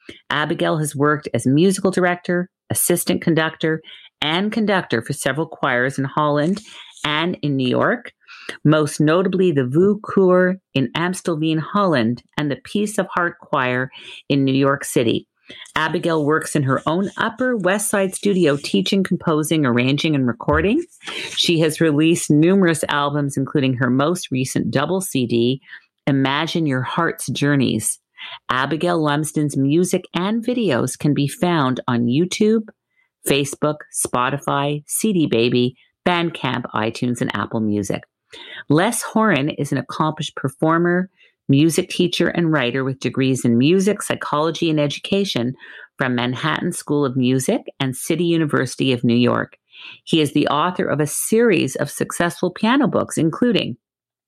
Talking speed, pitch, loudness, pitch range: 135 wpm, 155 Hz, -19 LUFS, 135-180 Hz